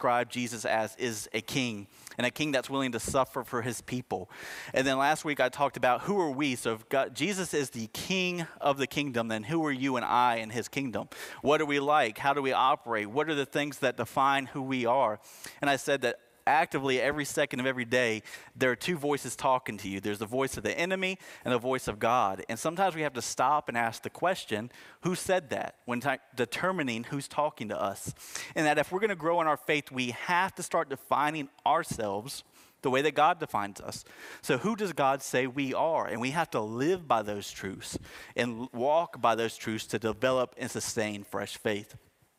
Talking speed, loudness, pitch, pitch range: 220 wpm, -30 LUFS, 130 Hz, 115-150 Hz